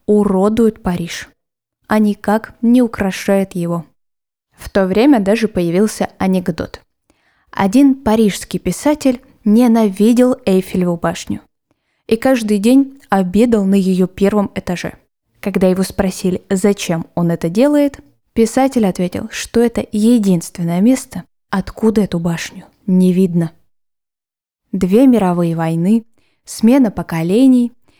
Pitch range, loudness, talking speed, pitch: 185-230 Hz, -15 LUFS, 105 wpm, 200 Hz